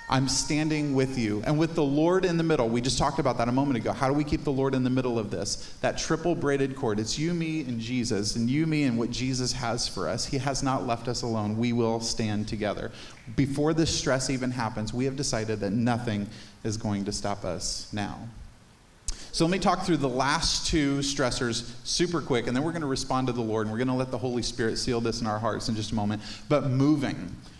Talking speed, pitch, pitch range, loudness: 245 wpm, 125 Hz, 110-140 Hz, -27 LUFS